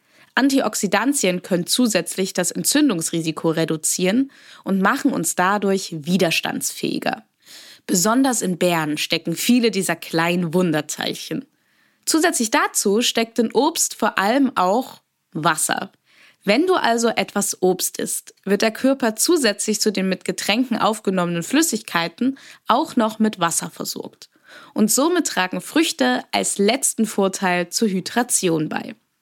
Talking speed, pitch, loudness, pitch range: 120 wpm, 205 Hz, -20 LUFS, 180-255 Hz